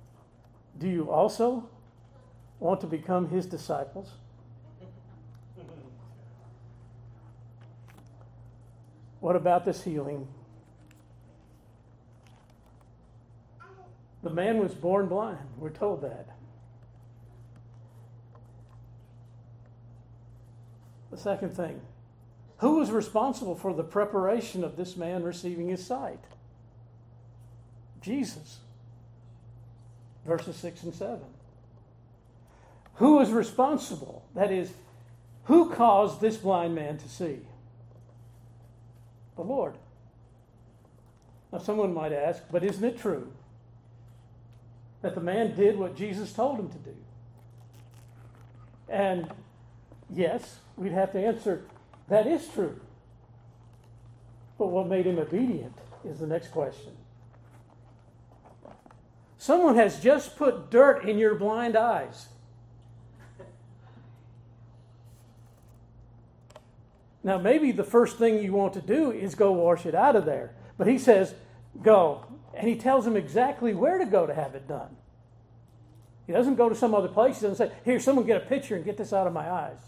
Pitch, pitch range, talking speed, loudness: 120 Hz, 115-190 Hz, 115 wpm, -27 LUFS